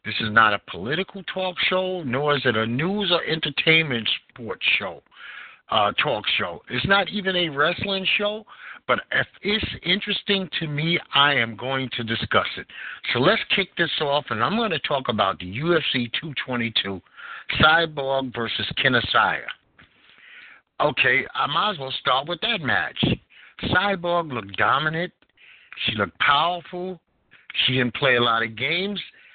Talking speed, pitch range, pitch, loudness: 160 wpm, 125-190 Hz, 160 Hz, -22 LUFS